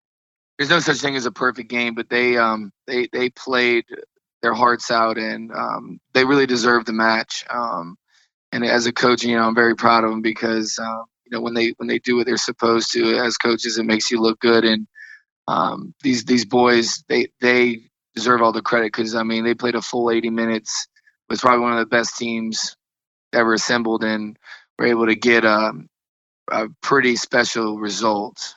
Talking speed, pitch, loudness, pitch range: 200 wpm, 115 Hz, -19 LUFS, 115-125 Hz